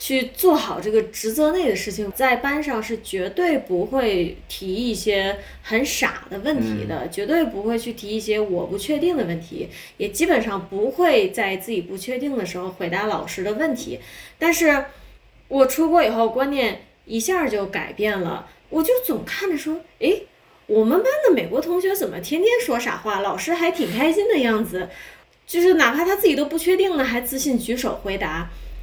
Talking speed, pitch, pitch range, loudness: 270 characters per minute, 245 Hz, 200-320 Hz, -21 LUFS